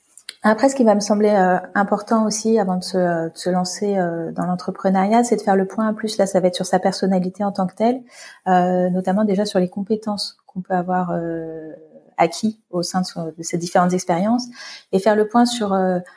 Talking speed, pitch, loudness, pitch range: 230 wpm, 190 Hz, -19 LUFS, 180-215 Hz